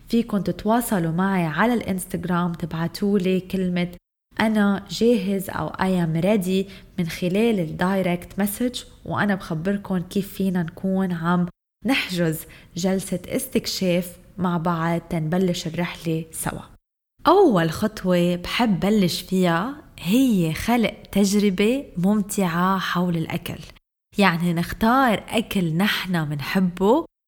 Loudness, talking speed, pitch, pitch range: -22 LUFS, 105 wpm, 185 Hz, 175-205 Hz